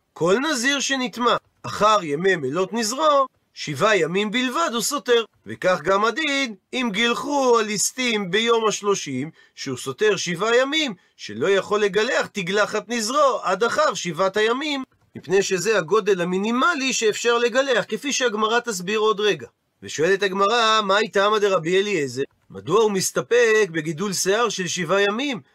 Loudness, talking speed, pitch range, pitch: -21 LUFS, 140 wpm, 195-240 Hz, 215 Hz